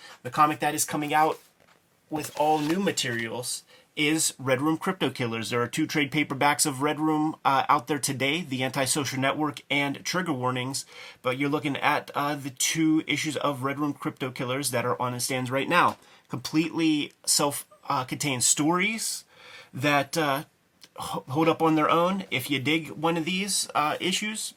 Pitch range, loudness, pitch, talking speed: 135-160 Hz, -26 LUFS, 150 Hz, 180 wpm